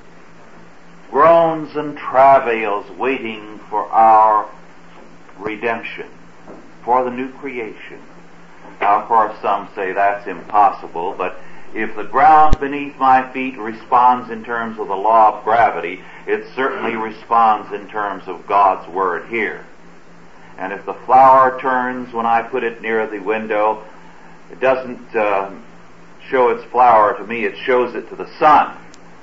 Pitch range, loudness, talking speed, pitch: 110-130 Hz, -16 LUFS, 140 wpm, 120 Hz